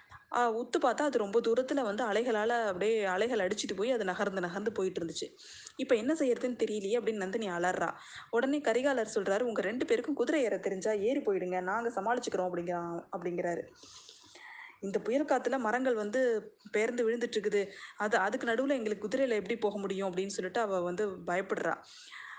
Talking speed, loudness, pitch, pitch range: 160 wpm, -32 LUFS, 220 Hz, 195-250 Hz